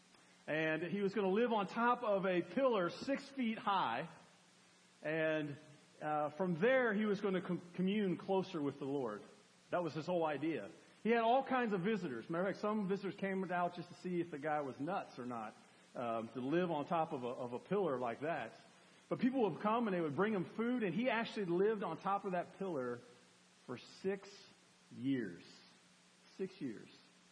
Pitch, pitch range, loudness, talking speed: 185 Hz, 155-210 Hz, -39 LUFS, 200 wpm